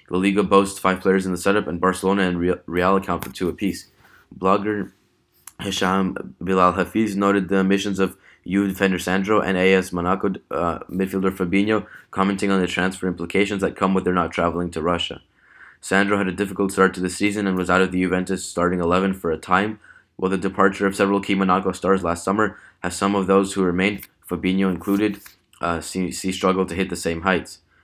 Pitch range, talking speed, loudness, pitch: 90-100 Hz, 205 wpm, -21 LUFS, 95 Hz